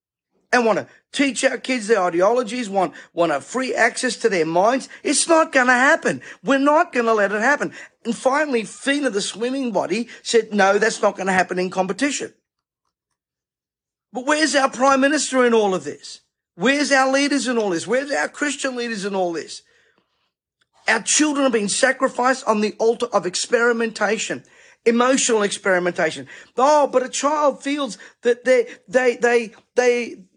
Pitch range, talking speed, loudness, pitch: 210-270 Hz, 165 wpm, -19 LUFS, 245 Hz